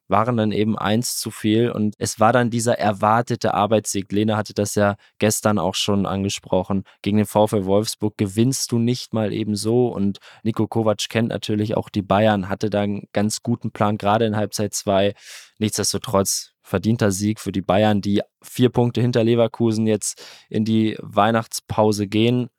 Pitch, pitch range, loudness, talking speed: 105 Hz, 100-115 Hz, -21 LUFS, 175 wpm